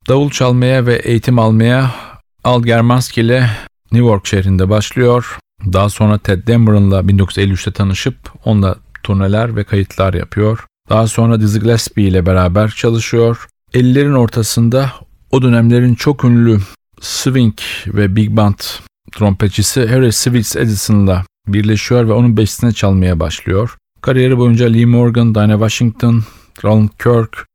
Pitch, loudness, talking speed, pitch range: 110 Hz, -12 LUFS, 130 wpm, 100-120 Hz